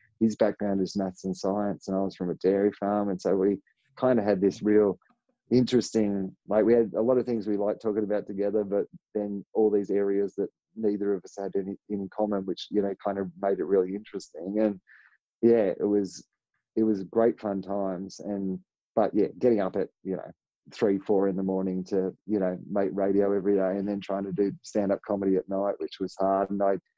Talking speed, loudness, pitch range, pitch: 220 wpm, -28 LUFS, 95-105 Hz, 100 Hz